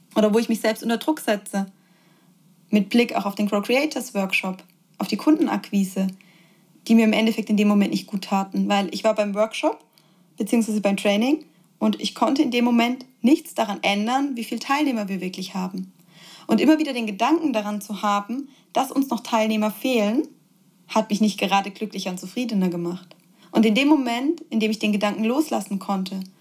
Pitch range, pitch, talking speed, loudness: 190-240 Hz, 210 Hz, 190 wpm, -22 LUFS